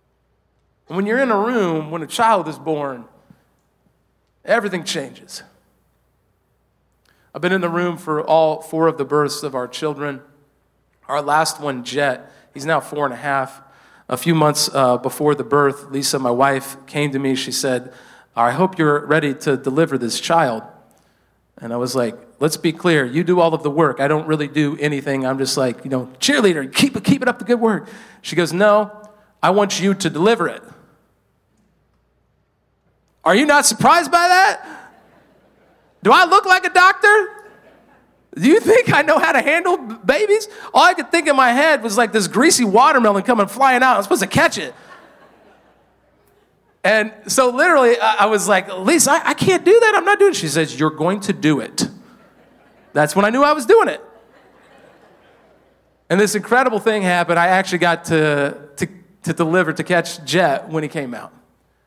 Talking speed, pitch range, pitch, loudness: 185 wpm, 145-235 Hz, 170 Hz, -16 LUFS